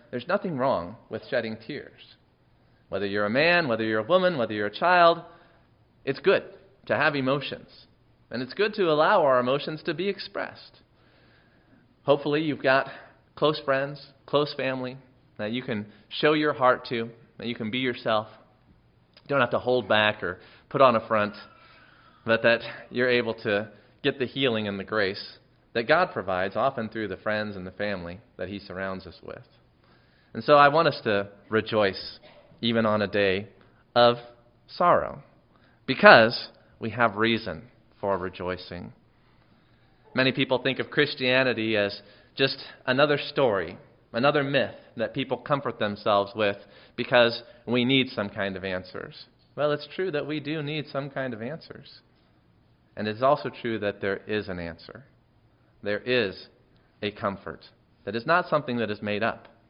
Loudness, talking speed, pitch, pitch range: -25 LUFS, 165 wpm, 115 Hz, 105-135 Hz